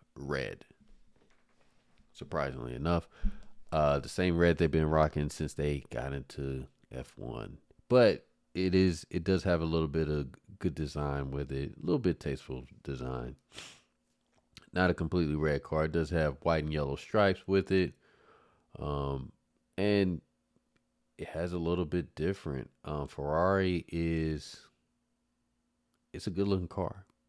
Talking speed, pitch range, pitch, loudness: 140 wpm, 70-90 Hz, 75 Hz, -32 LUFS